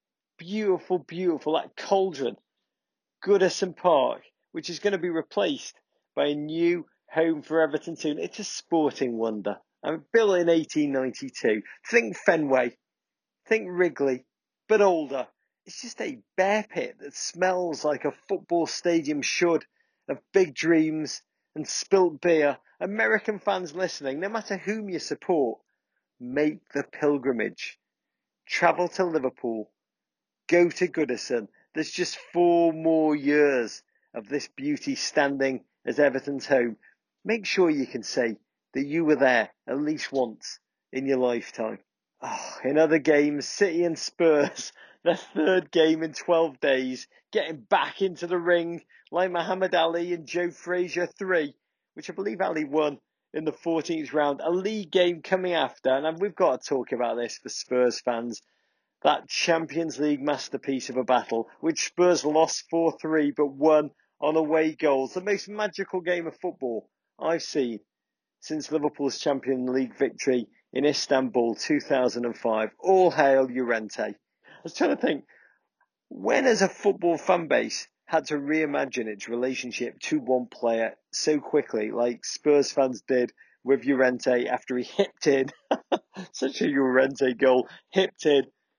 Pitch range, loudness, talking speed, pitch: 135-180 Hz, -26 LUFS, 150 wpm, 155 Hz